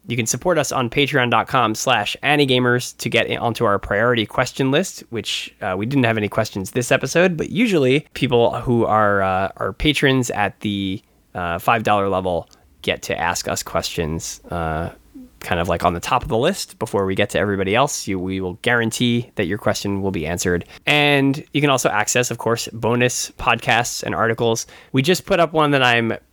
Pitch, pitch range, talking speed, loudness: 115 Hz, 100-130 Hz, 195 wpm, -19 LUFS